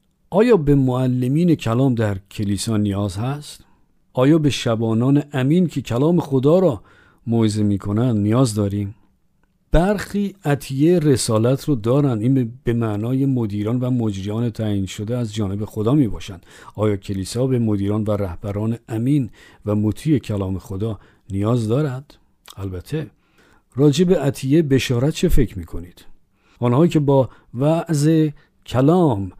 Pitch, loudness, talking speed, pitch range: 120 Hz, -19 LUFS, 135 wpm, 105-145 Hz